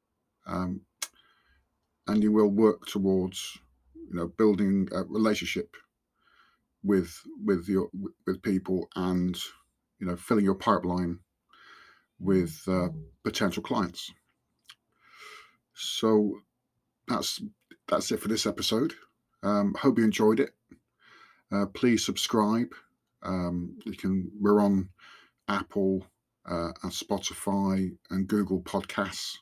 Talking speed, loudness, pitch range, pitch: 110 wpm, -29 LUFS, 90-105 Hz, 95 Hz